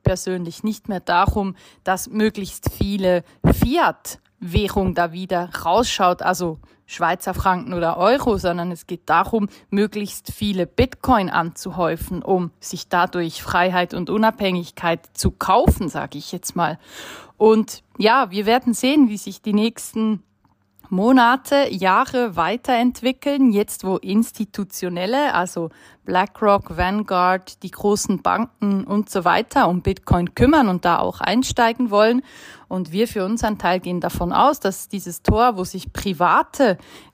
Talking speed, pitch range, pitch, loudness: 135 wpm, 180-225 Hz, 195 Hz, -20 LUFS